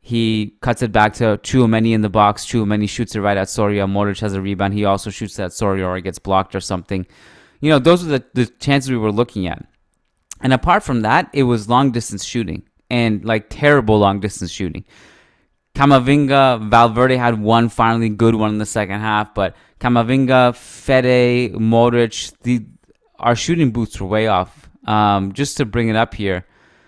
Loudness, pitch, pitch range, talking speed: -17 LUFS, 110 Hz, 100-125 Hz, 190 wpm